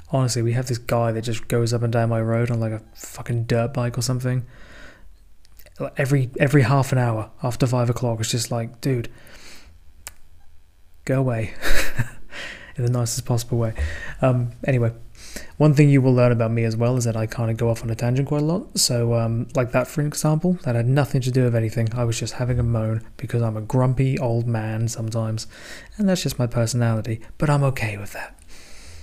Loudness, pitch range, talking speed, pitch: -22 LUFS, 115-130 Hz, 205 wpm, 120 Hz